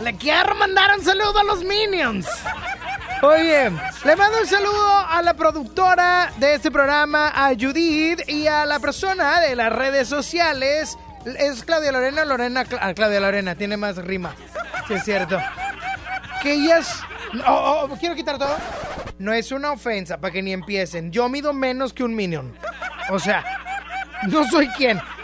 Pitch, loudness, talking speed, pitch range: 290 Hz, -20 LUFS, 160 wpm, 240-345 Hz